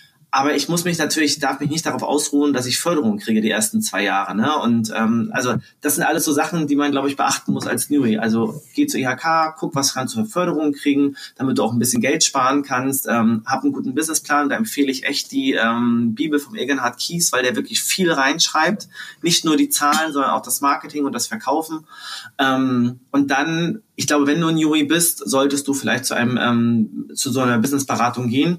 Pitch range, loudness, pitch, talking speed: 120-155 Hz, -19 LUFS, 140 Hz, 220 wpm